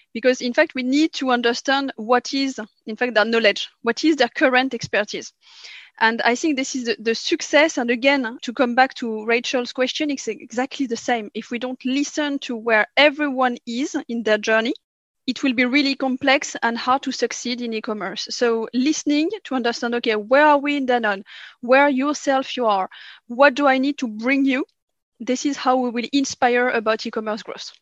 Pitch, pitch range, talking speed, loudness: 255 Hz, 235-280 Hz, 195 wpm, -20 LUFS